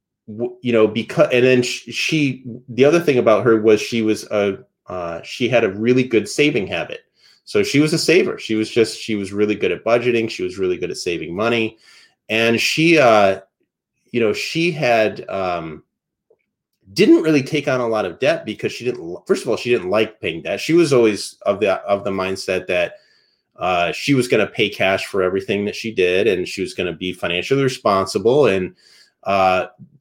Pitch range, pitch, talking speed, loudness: 105-145 Hz, 115 Hz, 205 wpm, -18 LUFS